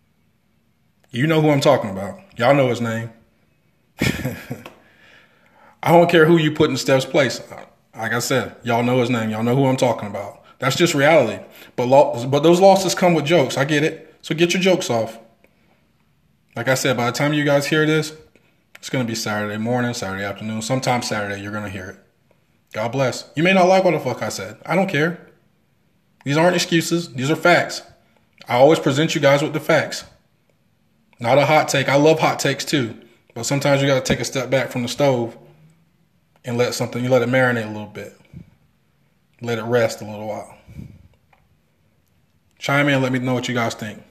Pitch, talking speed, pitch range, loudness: 135 Hz, 205 wpm, 115-155 Hz, -18 LUFS